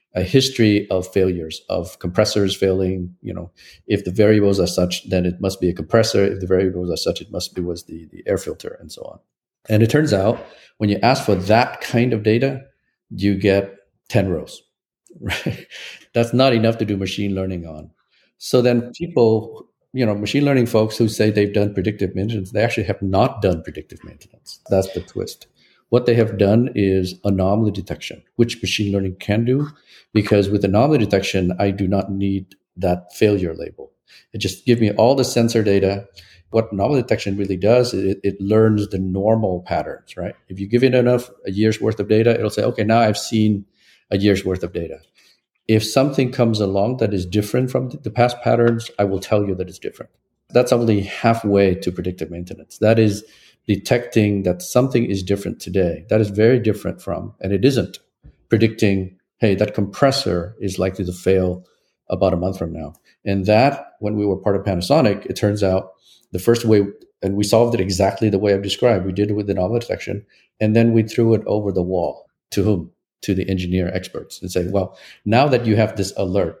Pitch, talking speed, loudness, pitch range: 100 Hz, 200 wpm, -19 LUFS, 95-115 Hz